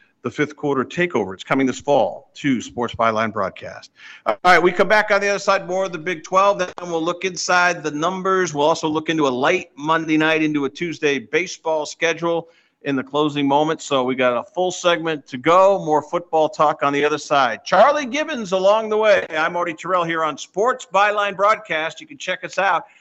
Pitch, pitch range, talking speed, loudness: 165 Hz, 150-185 Hz, 210 wpm, -19 LUFS